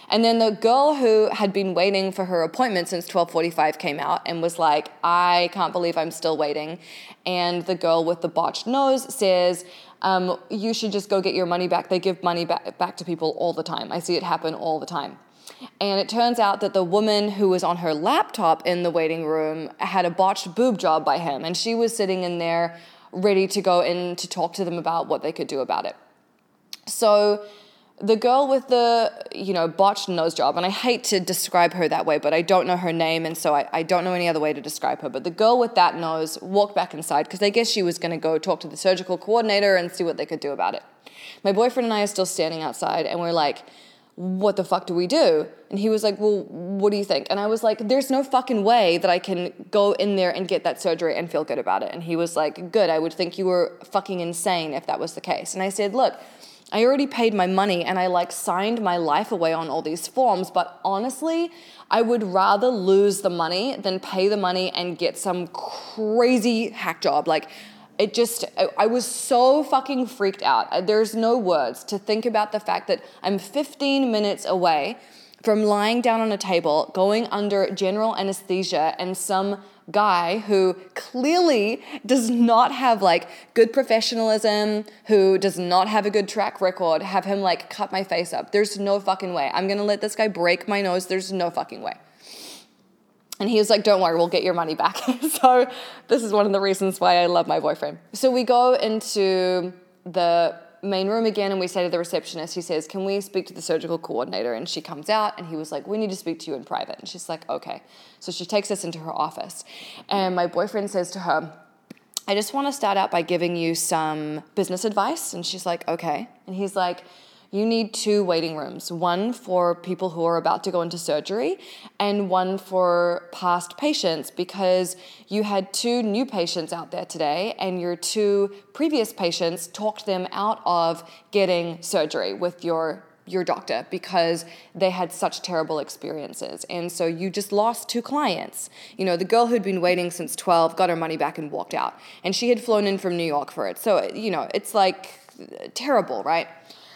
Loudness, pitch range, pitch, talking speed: -23 LUFS, 175-215 Hz, 190 Hz, 220 wpm